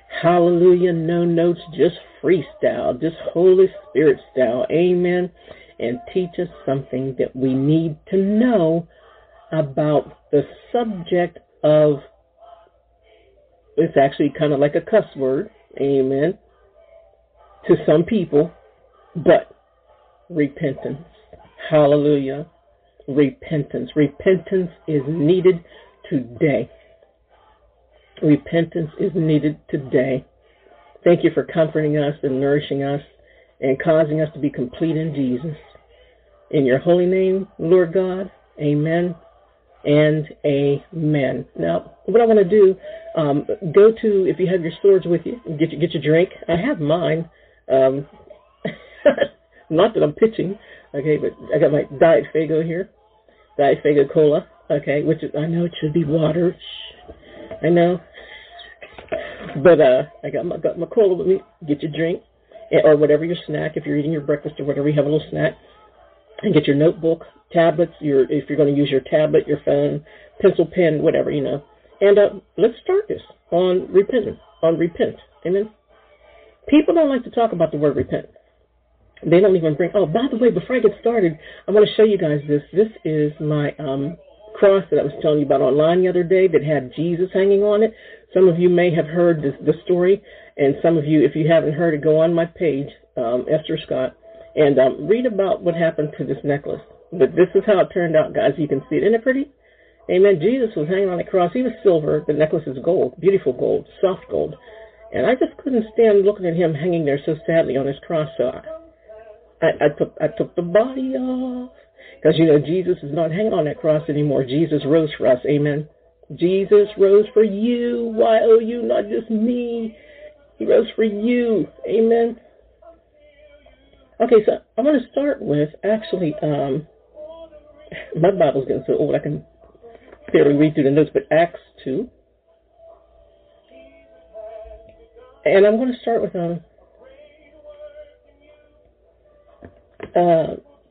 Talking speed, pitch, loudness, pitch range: 165 wpm, 175 Hz, -18 LUFS, 150-220 Hz